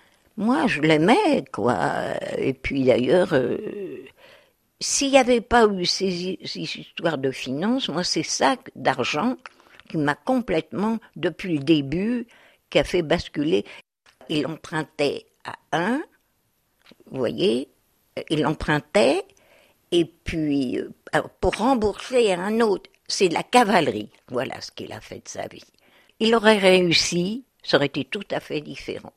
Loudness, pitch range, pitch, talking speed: -22 LUFS, 155-245 Hz, 185 Hz, 145 wpm